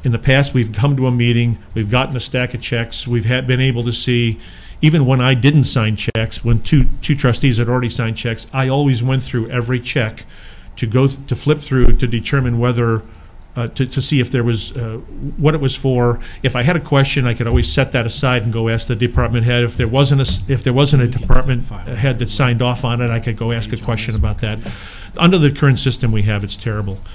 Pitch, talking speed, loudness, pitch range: 125 Hz, 240 wpm, -16 LUFS, 115-130 Hz